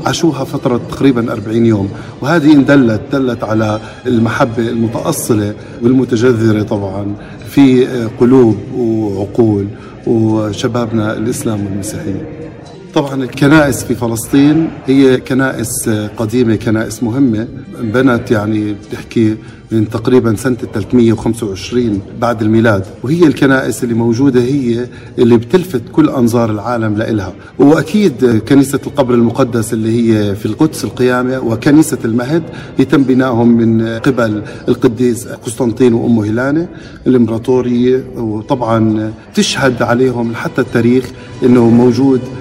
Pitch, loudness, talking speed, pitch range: 120 Hz, -12 LUFS, 105 wpm, 115-130 Hz